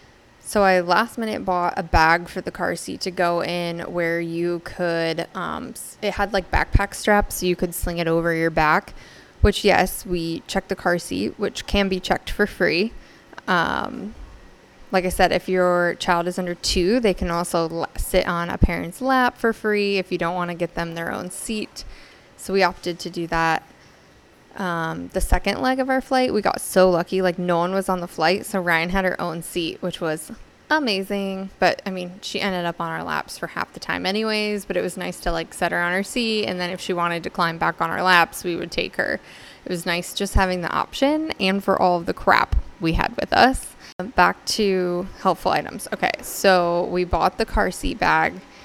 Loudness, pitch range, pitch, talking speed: -22 LUFS, 170-195 Hz, 180 Hz, 220 wpm